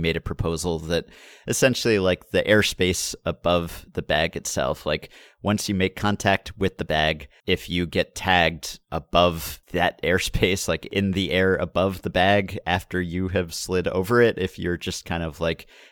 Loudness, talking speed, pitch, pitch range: -23 LUFS, 175 wpm, 90 Hz, 85-95 Hz